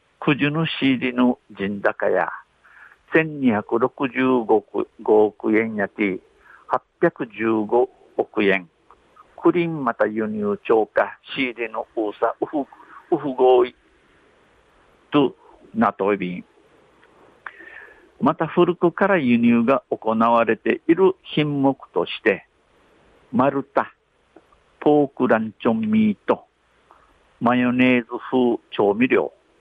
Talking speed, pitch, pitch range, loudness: 195 characters per minute, 130 Hz, 115-175 Hz, -21 LUFS